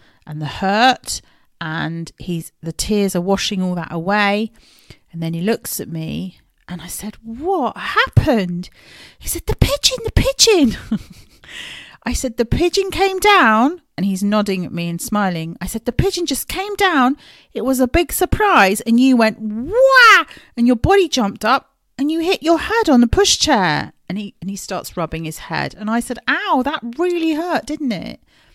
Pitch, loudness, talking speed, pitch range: 235 Hz, -17 LUFS, 185 wpm, 195-325 Hz